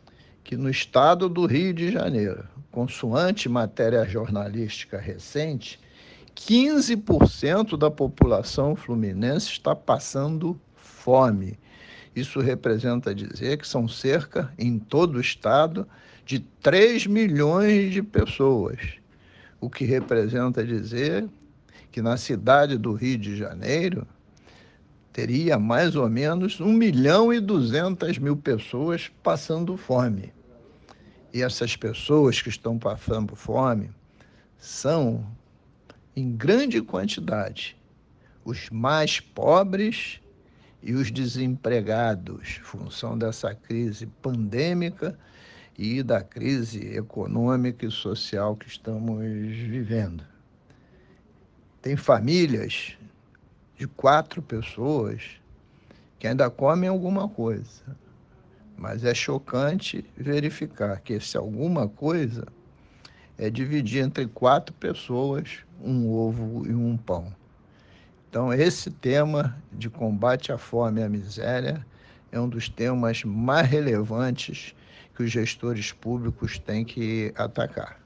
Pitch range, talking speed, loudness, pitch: 110-145 Hz, 105 wpm, -25 LUFS, 120 Hz